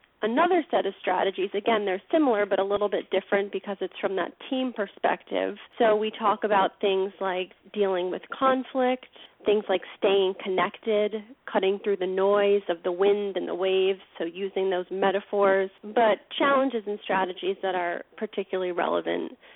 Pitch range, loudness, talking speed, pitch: 190-215 Hz, -26 LUFS, 165 wpm, 200 Hz